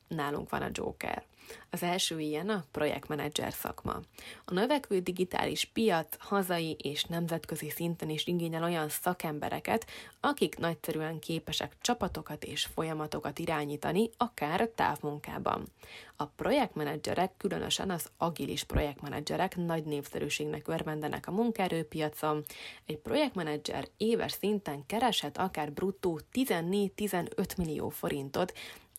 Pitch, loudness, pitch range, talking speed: 165 Hz, -34 LUFS, 150-190 Hz, 110 wpm